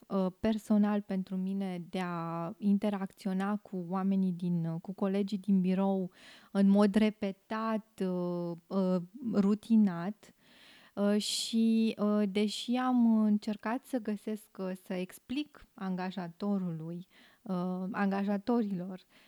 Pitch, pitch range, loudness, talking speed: 200 Hz, 185-215 Hz, -32 LUFS, 85 wpm